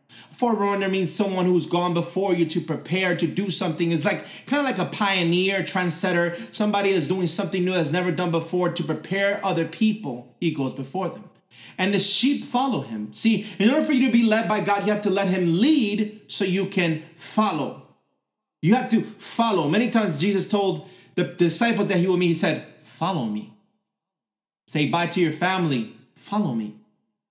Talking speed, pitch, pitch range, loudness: 190 wpm, 185 Hz, 170-210 Hz, -22 LUFS